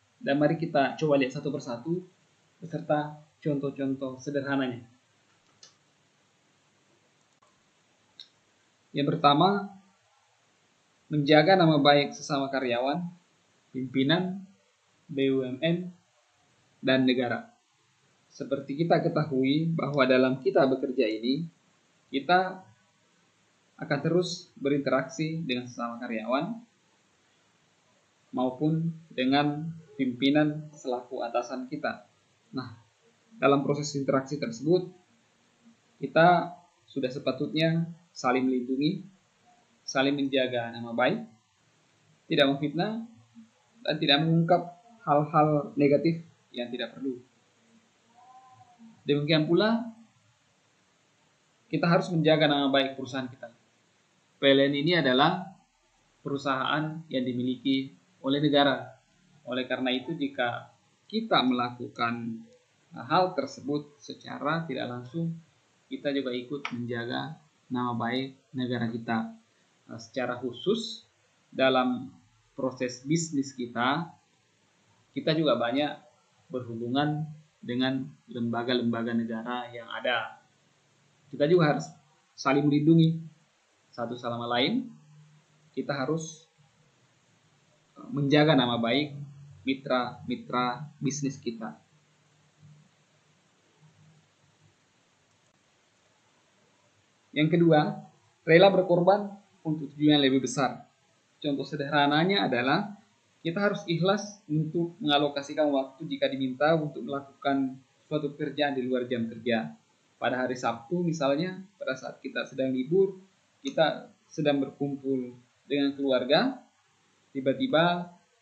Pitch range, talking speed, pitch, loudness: 130-160 Hz, 90 wpm, 145 Hz, -28 LUFS